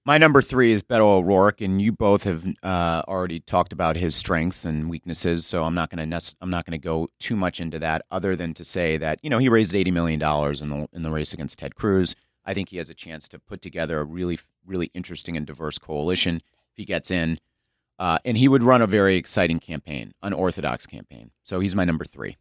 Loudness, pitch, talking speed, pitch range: -22 LUFS, 85 Hz, 225 wpm, 80-95 Hz